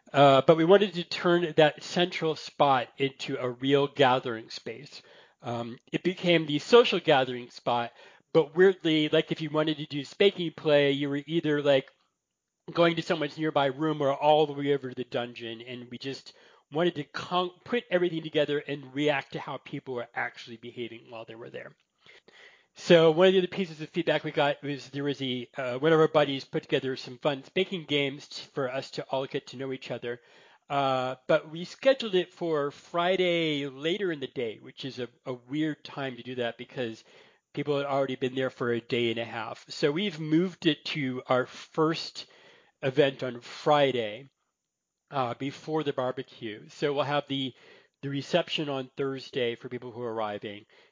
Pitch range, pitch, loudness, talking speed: 130-160 Hz, 145 Hz, -28 LUFS, 190 wpm